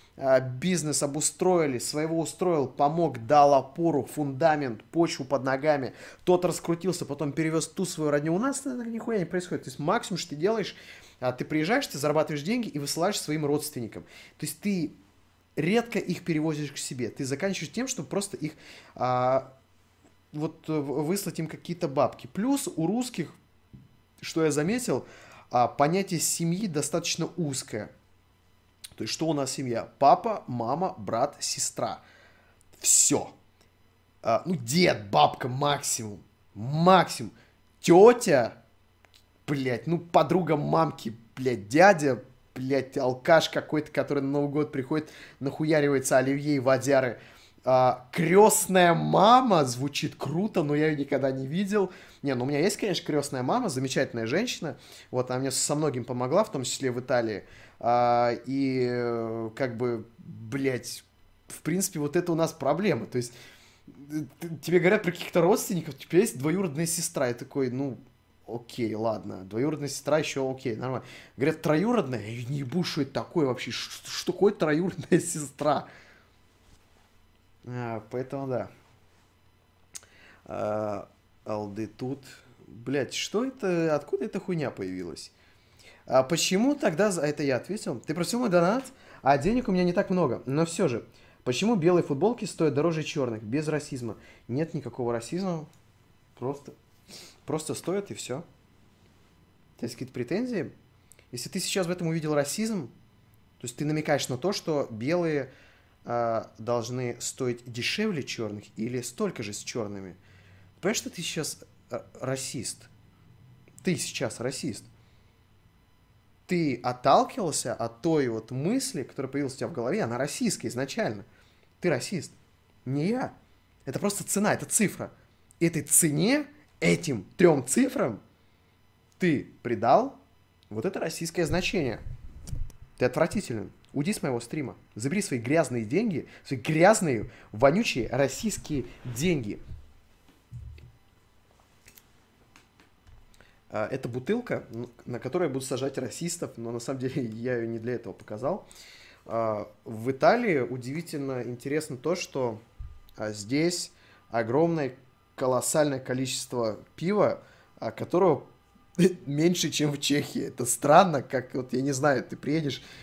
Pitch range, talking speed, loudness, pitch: 115-165 Hz, 130 wpm, -27 LUFS, 140 Hz